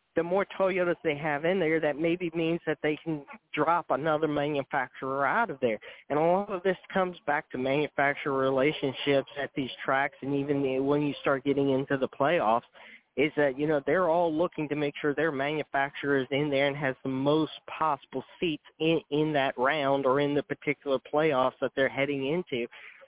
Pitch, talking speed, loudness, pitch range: 145 Hz, 200 wpm, -28 LUFS, 140-160 Hz